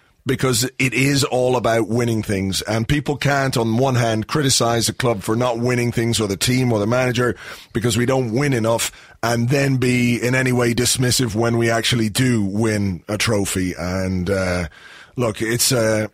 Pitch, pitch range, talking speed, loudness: 120 Hz, 110-125 Hz, 190 wpm, -19 LUFS